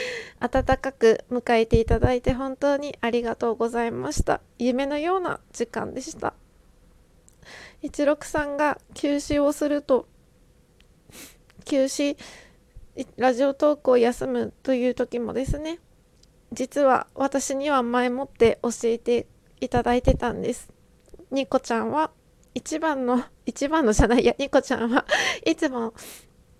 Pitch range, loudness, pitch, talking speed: 240-285 Hz, -24 LUFS, 265 Hz, 255 characters per minute